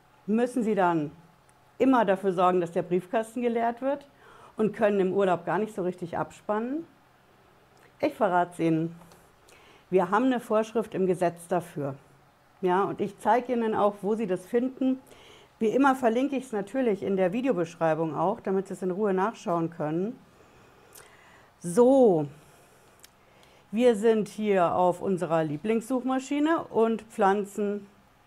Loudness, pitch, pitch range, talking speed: -27 LUFS, 195 Hz, 175-230 Hz, 140 wpm